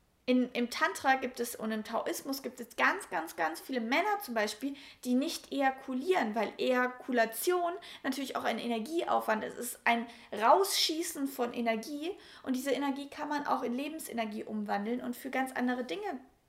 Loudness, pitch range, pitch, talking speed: -33 LUFS, 235-295 Hz, 260 Hz, 170 wpm